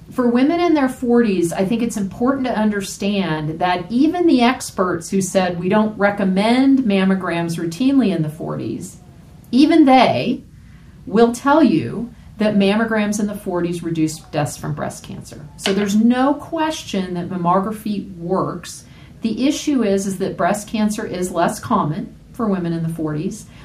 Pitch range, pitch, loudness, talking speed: 180-240 Hz, 205 Hz, -18 LUFS, 155 wpm